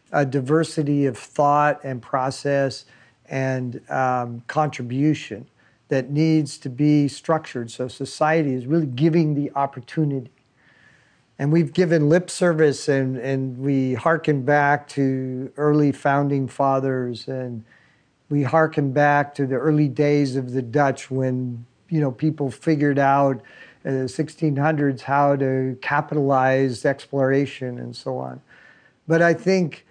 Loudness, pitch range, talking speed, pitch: -21 LUFS, 130-150 Hz, 130 wpm, 140 Hz